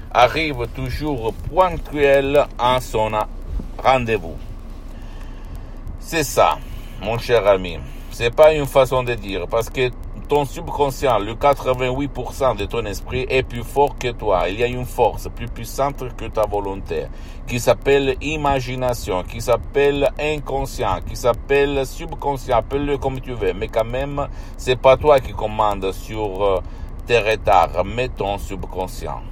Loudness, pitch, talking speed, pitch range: -20 LUFS, 125 Hz, 140 wpm, 105-140 Hz